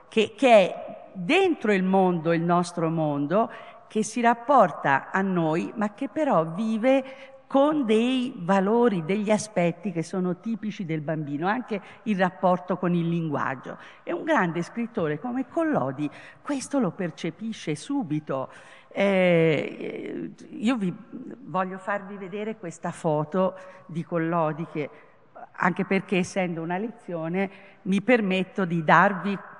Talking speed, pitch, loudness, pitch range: 130 wpm, 195 Hz, -25 LUFS, 170-230 Hz